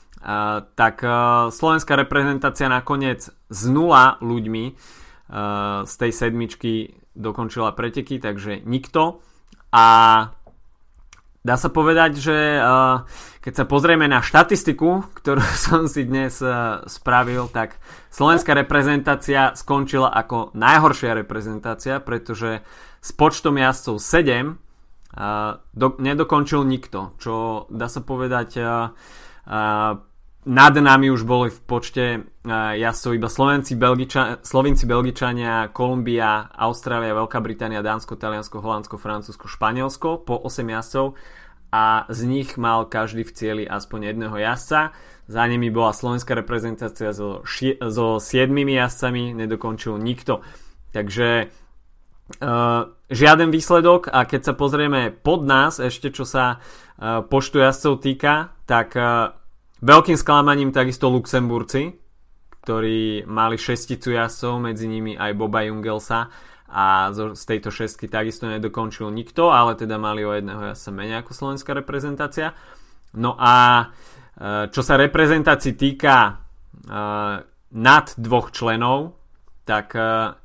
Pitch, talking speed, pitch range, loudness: 120 Hz, 125 wpm, 110-135 Hz, -19 LUFS